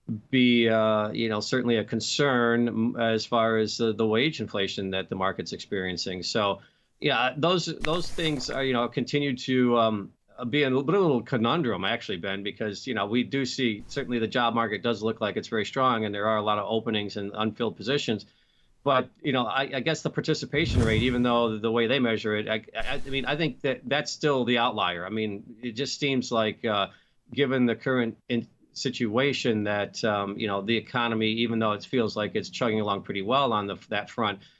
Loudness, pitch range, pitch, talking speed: -27 LUFS, 110-130 Hz, 115 Hz, 210 wpm